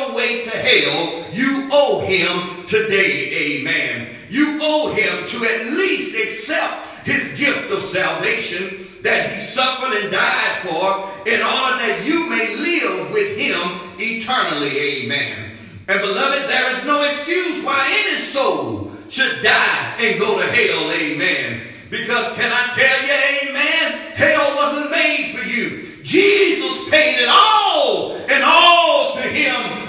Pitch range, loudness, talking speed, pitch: 215-325 Hz, -16 LUFS, 135 wpm, 275 Hz